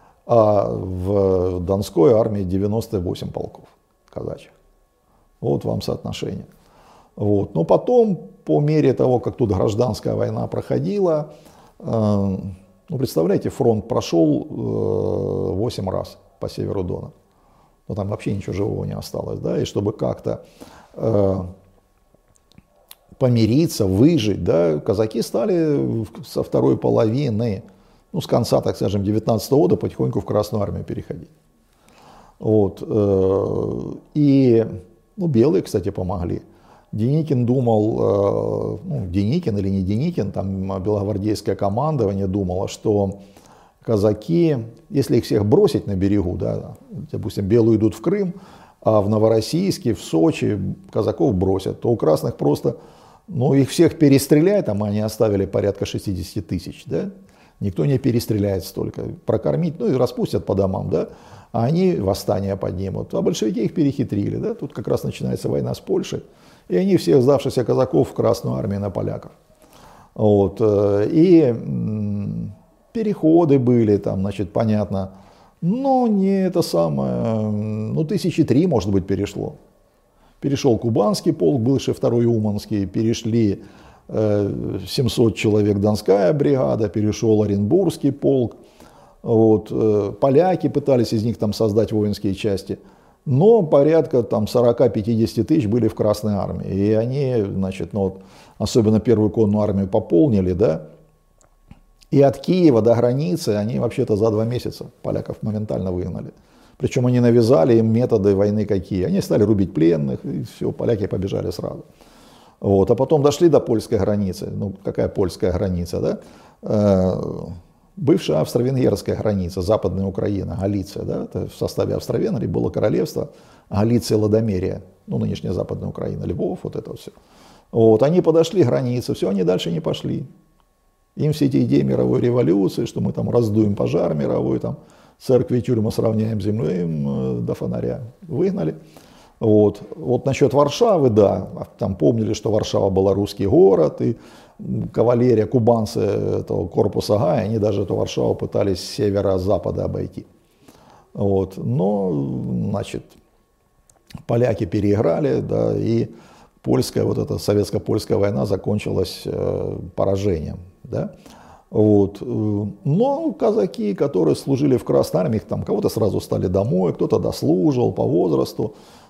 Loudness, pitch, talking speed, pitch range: -20 LUFS, 110 Hz, 130 wpm, 100-125 Hz